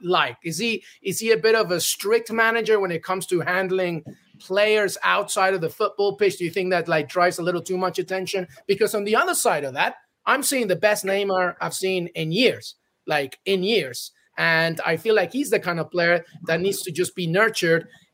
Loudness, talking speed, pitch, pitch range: -22 LUFS, 220 wpm, 185 Hz, 175-210 Hz